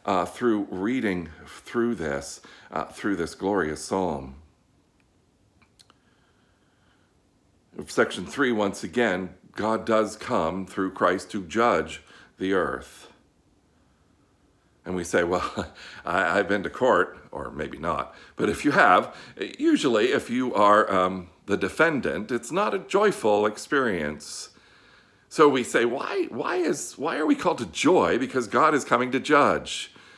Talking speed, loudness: 135 wpm, -24 LUFS